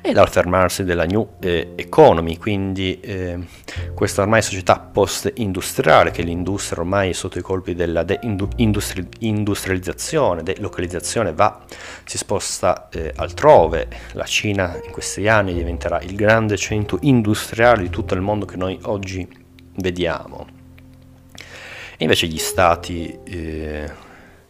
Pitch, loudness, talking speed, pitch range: 95 Hz, -19 LUFS, 125 wpm, 85-100 Hz